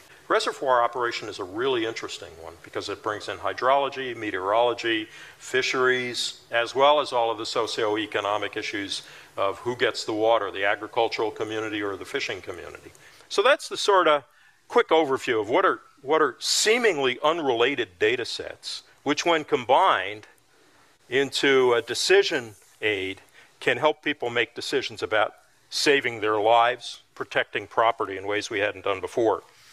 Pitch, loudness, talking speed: 135 Hz, -24 LUFS, 150 wpm